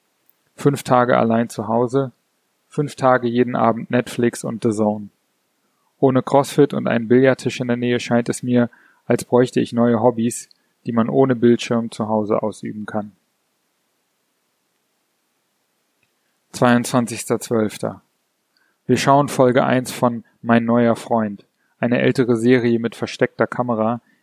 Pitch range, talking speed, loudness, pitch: 115-125 Hz, 130 wpm, -19 LUFS, 120 Hz